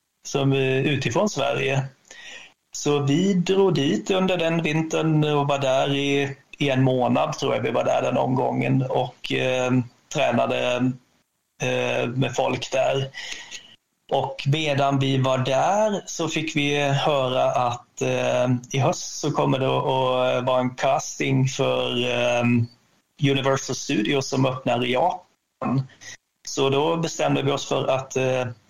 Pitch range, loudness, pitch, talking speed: 125-145 Hz, -23 LUFS, 135 Hz, 140 wpm